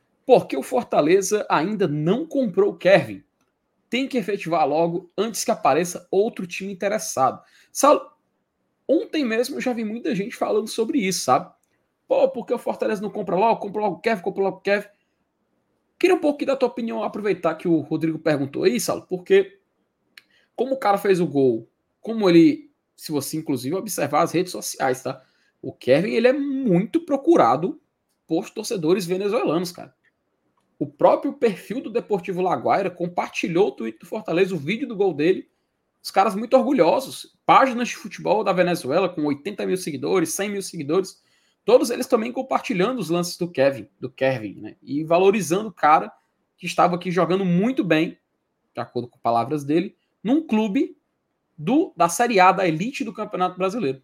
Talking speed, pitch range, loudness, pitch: 170 wpm, 175-245 Hz, -22 LUFS, 200 Hz